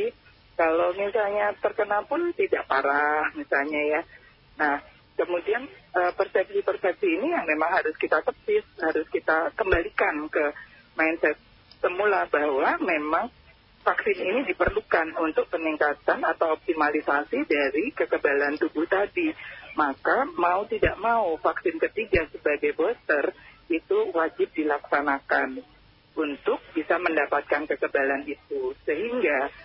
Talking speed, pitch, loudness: 110 wpm, 230 Hz, -25 LUFS